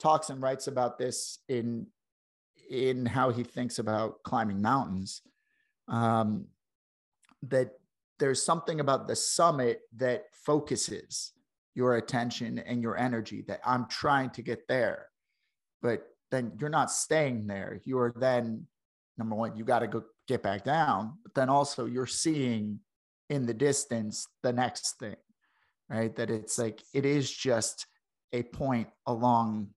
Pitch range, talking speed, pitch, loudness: 115-135 Hz, 145 wpm, 125 Hz, -31 LUFS